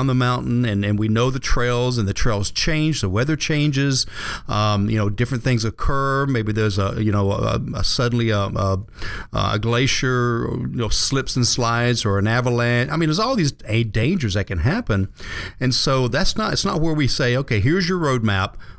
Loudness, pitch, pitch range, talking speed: -20 LUFS, 120 Hz, 105-135 Hz, 200 wpm